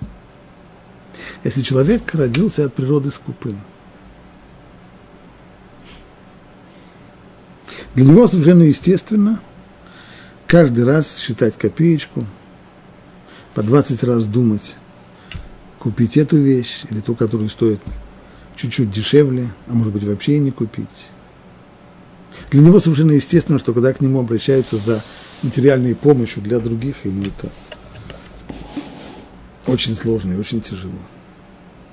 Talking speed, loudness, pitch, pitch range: 105 wpm, -16 LUFS, 125 Hz, 110-145 Hz